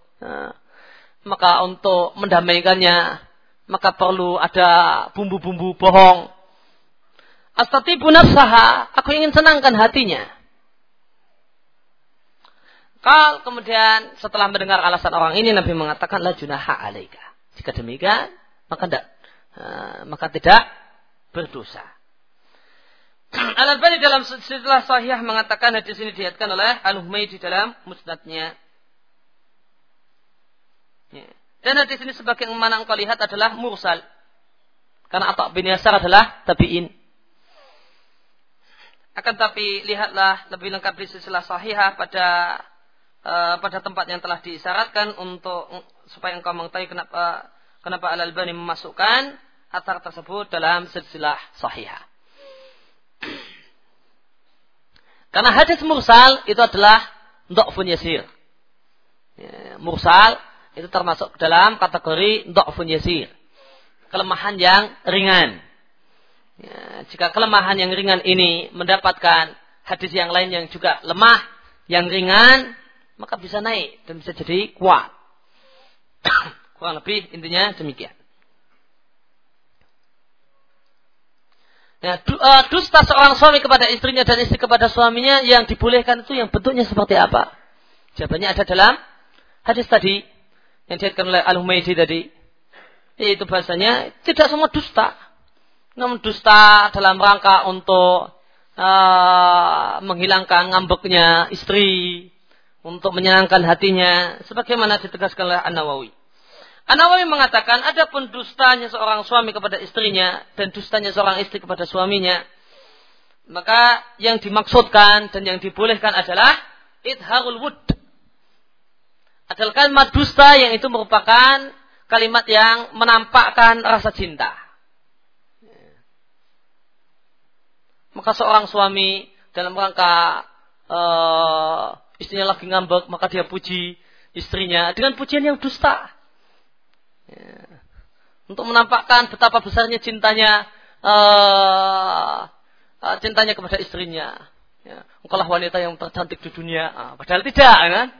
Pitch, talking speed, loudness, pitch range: 200 Hz, 100 wpm, -15 LUFS, 180-235 Hz